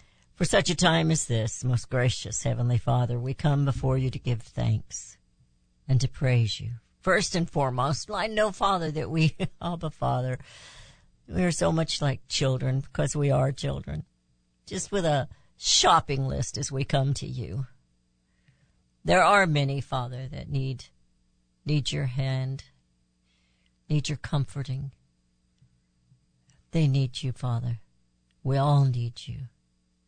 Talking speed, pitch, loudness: 145 wpm, 130 Hz, -27 LUFS